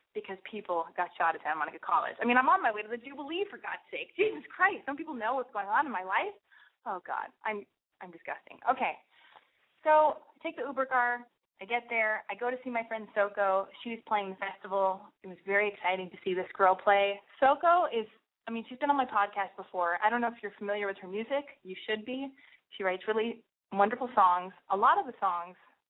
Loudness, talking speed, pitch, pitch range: -31 LUFS, 225 wpm, 215 Hz, 195-255 Hz